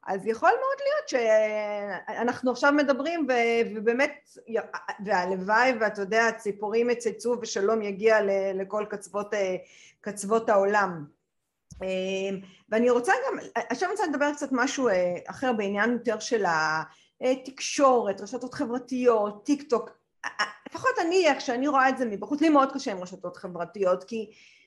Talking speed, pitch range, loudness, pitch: 125 wpm, 200-265 Hz, -26 LUFS, 225 Hz